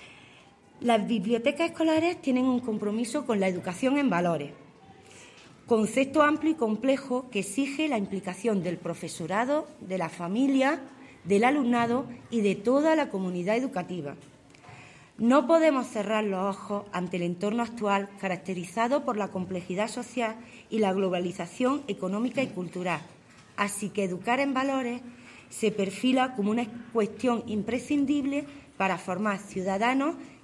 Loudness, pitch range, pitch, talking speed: -28 LUFS, 190-260 Hz, 220 Hz, 130 wpm